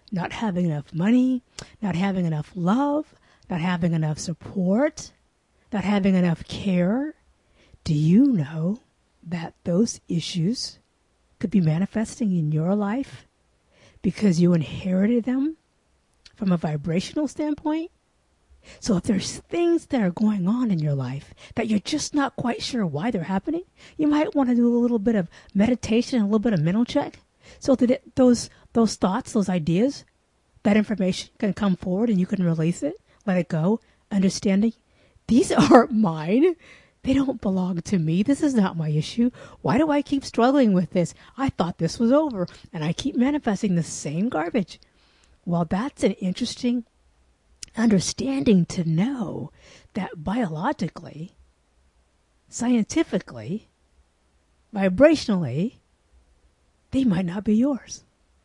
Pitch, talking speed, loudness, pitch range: 200 Hz, 145 wpm, -23 LUFS, 170-245 Hz